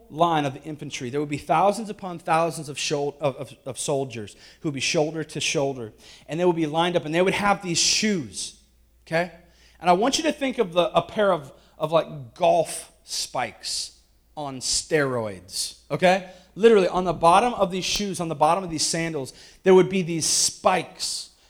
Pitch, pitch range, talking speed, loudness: 165 Hz, 145-180 Hz, 200 wpm, -23 LUFS